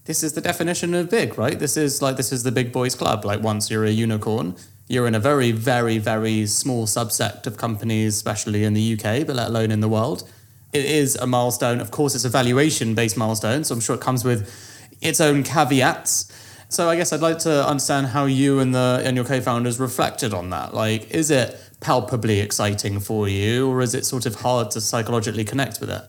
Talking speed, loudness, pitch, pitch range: 220 wpm, -21 LUFS, 120 Hz, 110-135 Hz